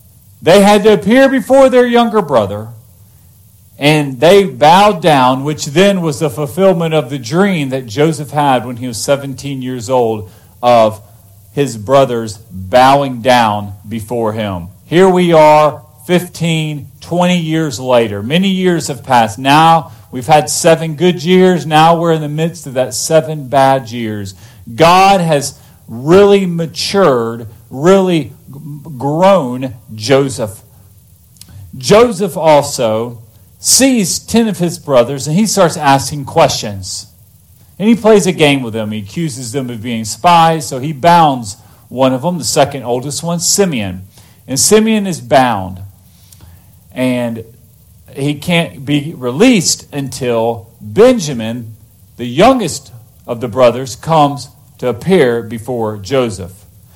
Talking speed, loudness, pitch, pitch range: 135 wpm, -11 LUFS, 135 Hz, 115-165 Hz